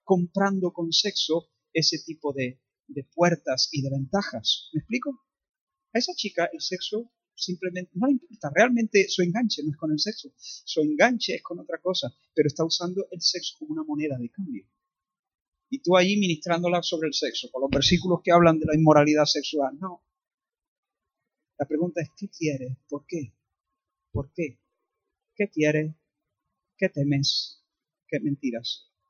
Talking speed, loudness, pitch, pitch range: 160 wpm, -25 LUFS, 175 Hz, 150-205 Hz